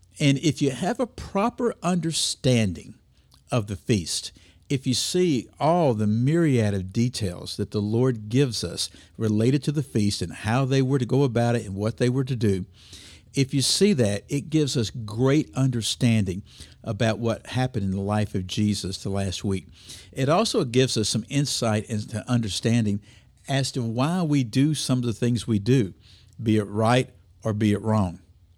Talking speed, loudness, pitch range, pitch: 185 wpm, -24 LUFS, 105-135 Hz, 115 Hz